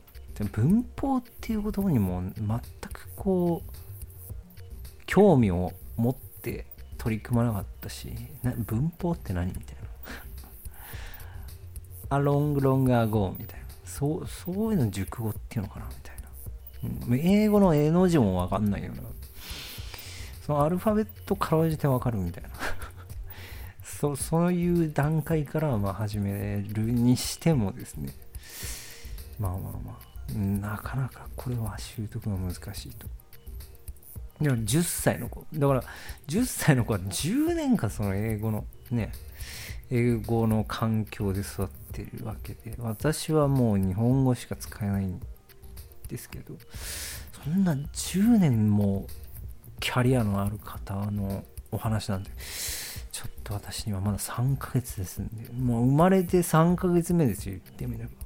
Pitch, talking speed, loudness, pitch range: 105 Hz, 260 characters per minute, -28 LUFS, 95-135 Hz